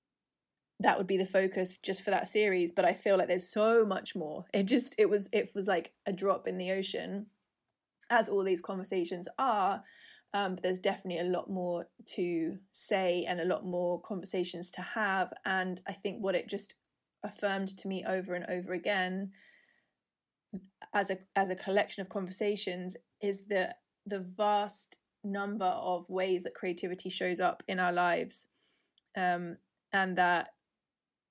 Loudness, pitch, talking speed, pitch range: -33 LUFS, 190 Hz, 165 wpm, 180-200 Hz